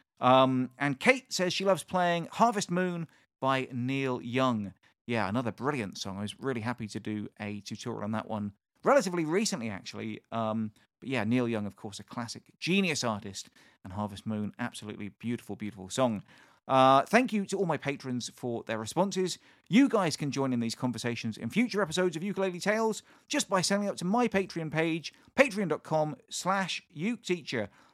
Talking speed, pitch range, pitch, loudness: 175 wpm, 110-185 Hz, 130 Hz, -30 LUFS